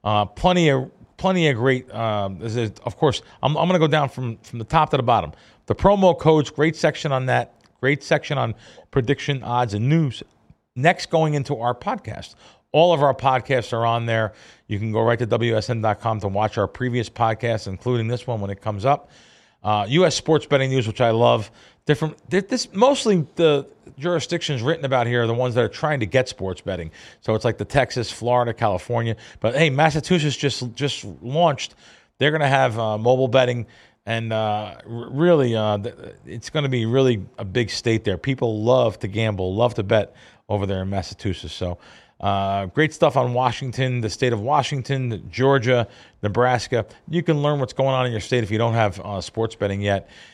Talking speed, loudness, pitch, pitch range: 200 wpm, -21 LUFS, 125 Hz, 110-145 Hz